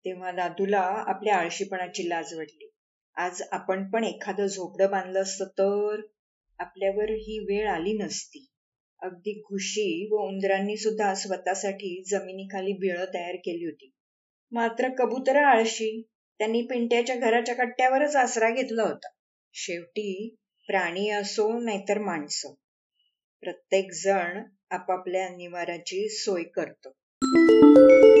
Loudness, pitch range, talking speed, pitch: -25 LUFS, 185-215 Hz, 110 wpm, 195 Hz